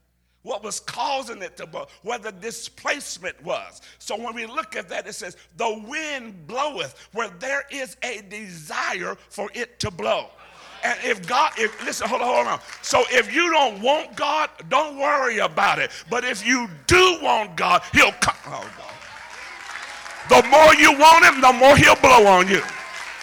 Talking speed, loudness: 180 wpm, -18 LUFS